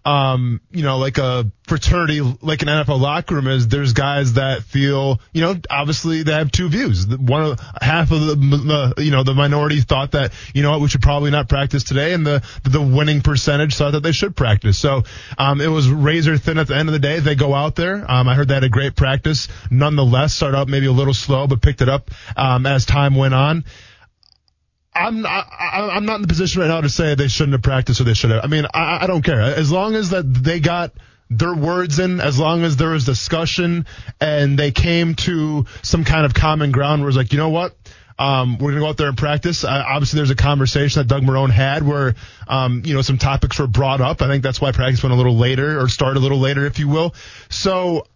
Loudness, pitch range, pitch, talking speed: -17 LUFS, 130-155 Hz, 140 Hz, 240 wpm